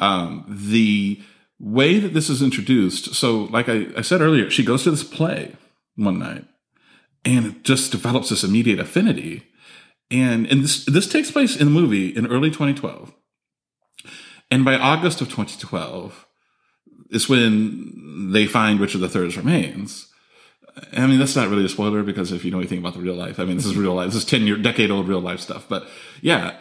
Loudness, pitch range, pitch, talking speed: -19 LUFS, 100-135 Hz, 120 Hz, 190 wpm